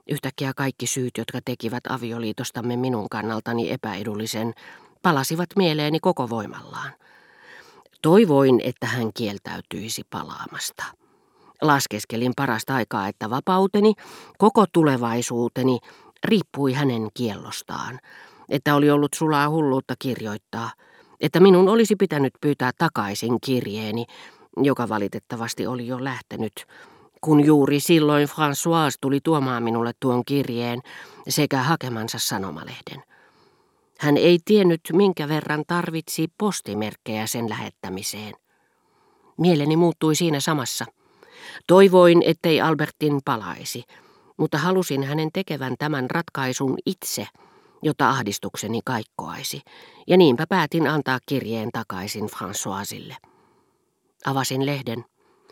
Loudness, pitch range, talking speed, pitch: -22 LUFS, 120-170 Hz, 100 wpm, 140 Hz